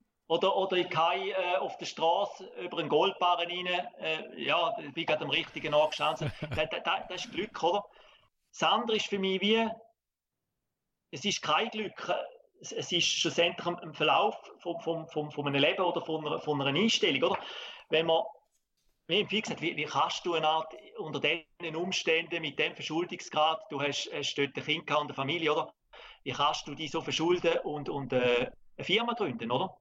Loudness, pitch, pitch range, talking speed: -30 LUFS, 165 Hz, 150-180 Hz, 185 wpm